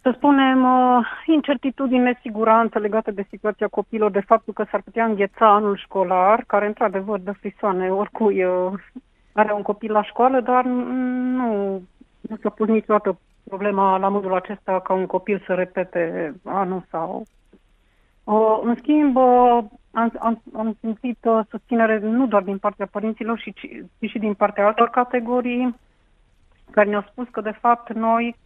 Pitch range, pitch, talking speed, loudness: 205-245 Hz, 220 Hz, 150 wpm, -20 LUFS